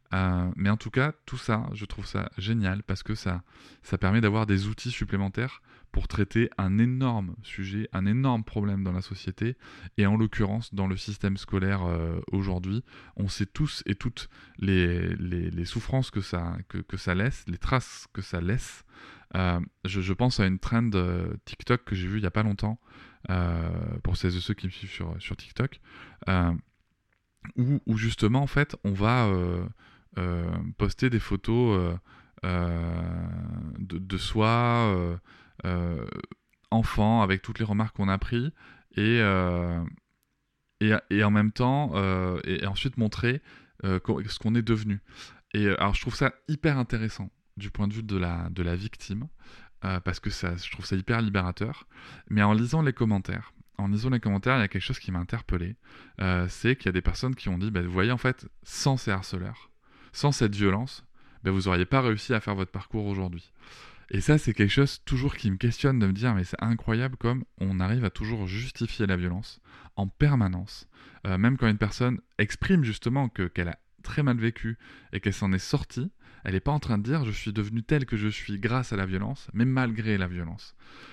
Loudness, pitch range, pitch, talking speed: -28 LUFS, 95-115 Hz, 105 Hz, 200 wpm